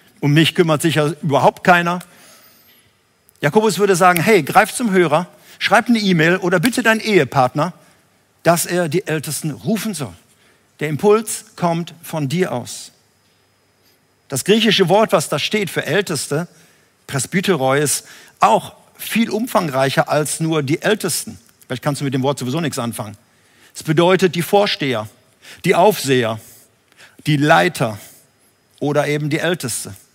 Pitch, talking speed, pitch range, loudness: 160 Hz, 140 wpm, 135-185 Hz, -17 LUFS